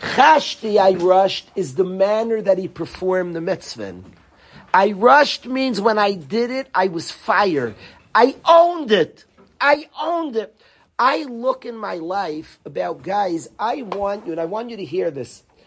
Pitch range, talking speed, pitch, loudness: 185-260 Hz, 170 wpm, 210 Hz, -19 LUFS